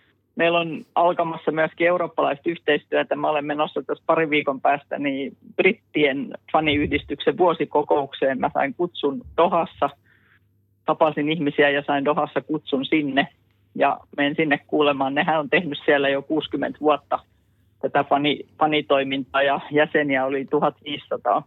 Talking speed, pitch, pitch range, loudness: 130 wpm, 145 Hz, 135-155 Hz, -22 LUFS